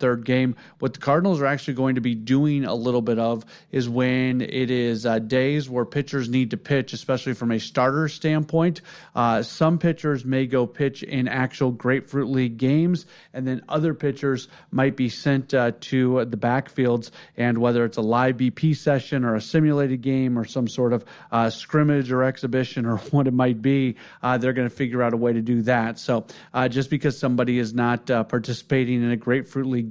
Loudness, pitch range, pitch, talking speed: -23 LUFS, 120-140 Hz, 130 Hz, 205 wpm